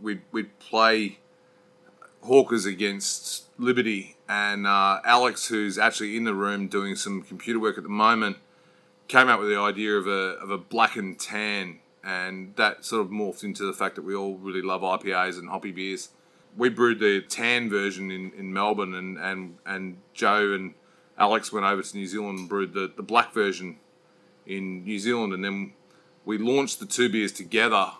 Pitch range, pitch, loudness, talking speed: 95-105 Hz, 100 Hz, -25 LUFS, 185 wpm